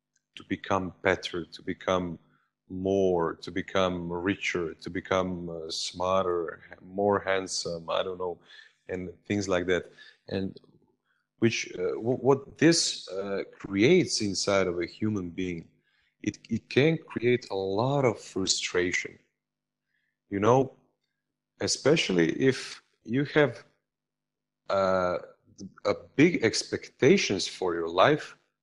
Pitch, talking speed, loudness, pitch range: 95 Hz, 105 wpm, -28 LUFS, 90-115 Hz